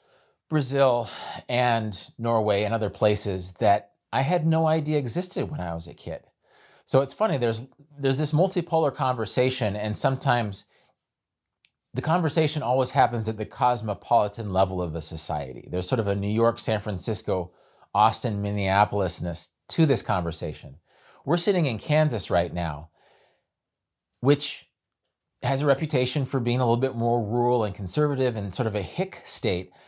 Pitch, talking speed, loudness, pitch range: 120 Hz, 155 wpm, -25 LUFS, 100-140 Hz